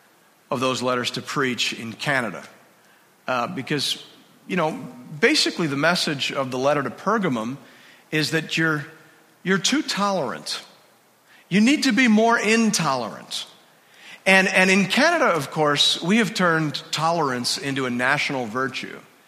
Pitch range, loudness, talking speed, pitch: 135-190 Hz, -21 LUFS, 140 wpm, 160 Hz